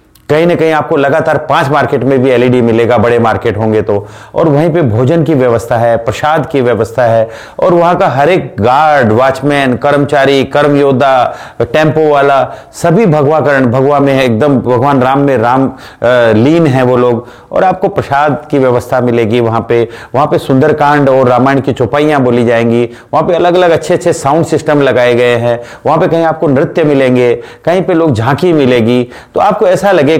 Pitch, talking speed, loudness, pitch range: 135 Hz, 190 wpm, -9 LUFS, 120-150 Hz